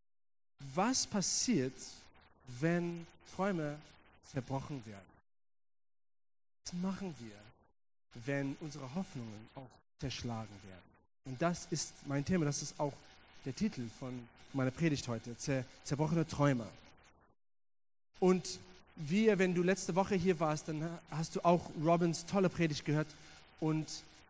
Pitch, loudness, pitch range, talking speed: 140 Hz, -36 LUFS, 110-170 Hz, 120 wpm